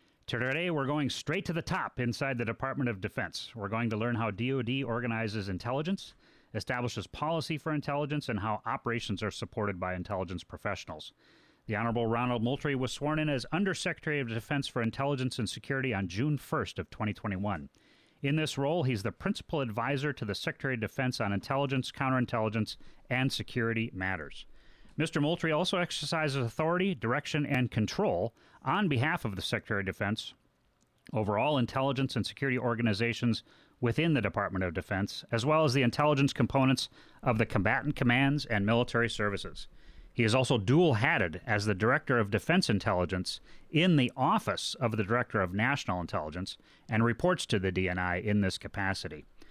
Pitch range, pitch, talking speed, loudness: 105-140 Hz, 120 Hz, 165 wpm, -31 LUFS